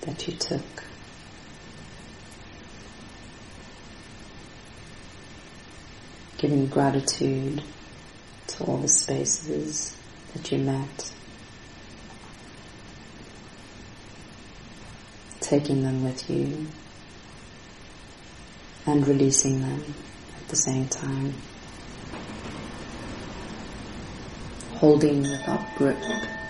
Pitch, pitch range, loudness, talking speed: 130 Hz, 105-140 Hz, -26 LUFS, 60 wpm